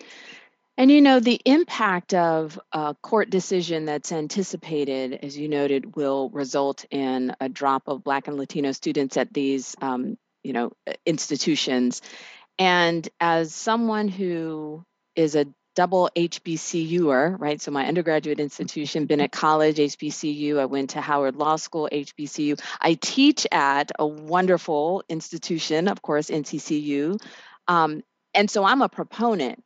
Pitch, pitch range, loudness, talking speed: 155 Hz, 145-180 Hz, -23 LUFS, 140 wpm